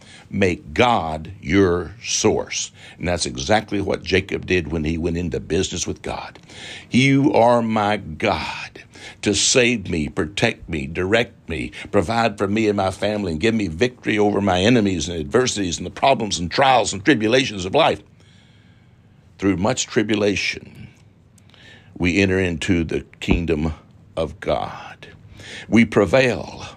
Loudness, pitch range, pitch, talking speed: -20 LUFS, 90-110 Hz, 100 Hz, 145 wpm